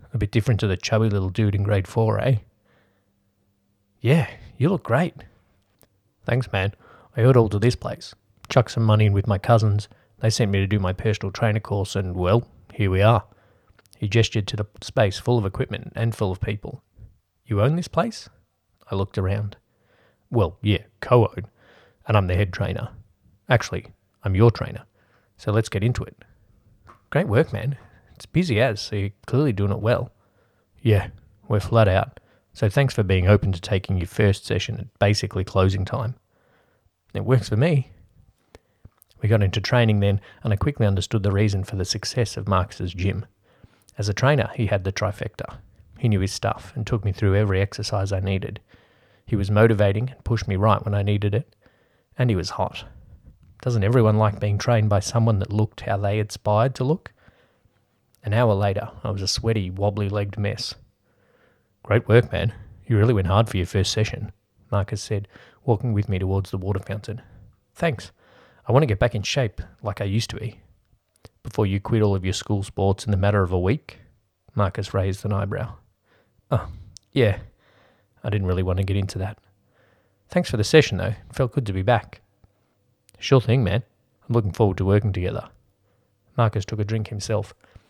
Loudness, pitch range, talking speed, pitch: -23 LUFS, 100-115 Hz, 190 wpm, 105 Hz